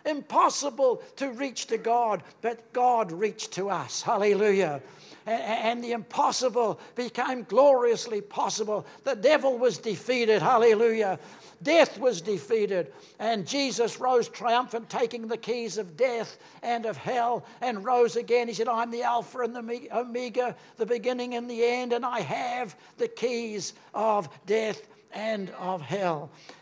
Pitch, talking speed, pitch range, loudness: 235 Hz, 140 wpm, 215-250 Hz, -27 LUFS